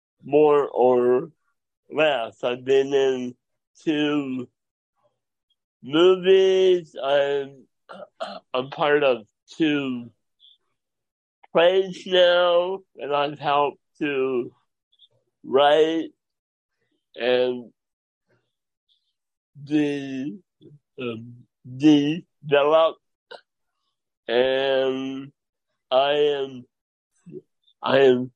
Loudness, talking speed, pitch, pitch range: -22 LUFS, 65 wpm, 145 Hz, 130-160 Hz